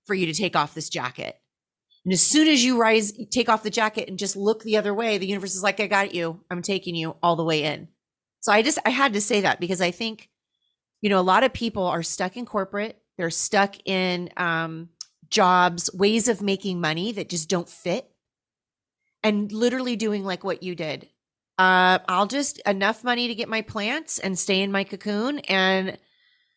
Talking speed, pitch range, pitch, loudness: 210 wpm, 180-220 Hz, 195 Hz, -22 LUFS